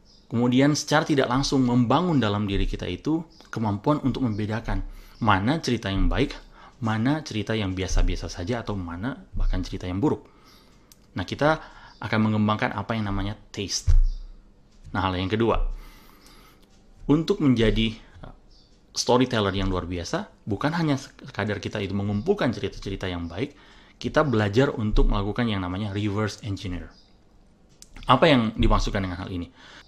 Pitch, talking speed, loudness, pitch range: 105 Hz, 135 wpm, -25 LUFS, 95-125 Hz